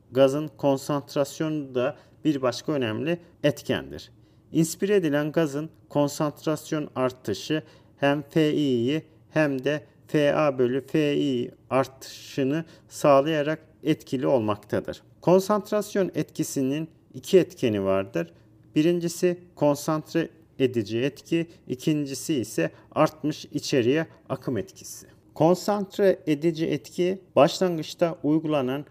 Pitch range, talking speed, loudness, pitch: 130-160 Hz, 90 wpm, -26 LUFS, 150 Hz